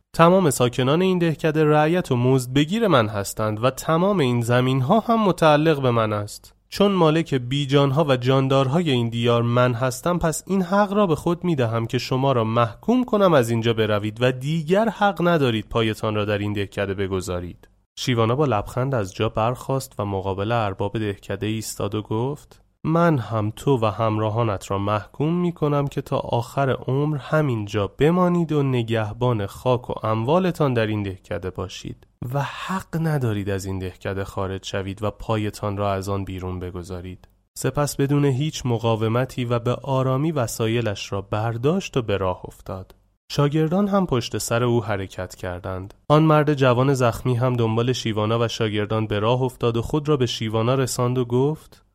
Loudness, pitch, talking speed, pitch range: -22 LUFS, 125 Hz, 175 wpm, 105-145 Hz